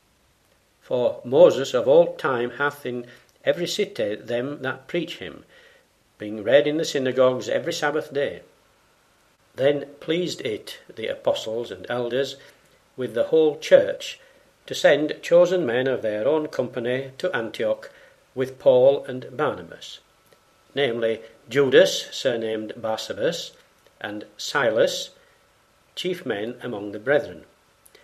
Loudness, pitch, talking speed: -23 LUFS, 150 Hz, 120 wpm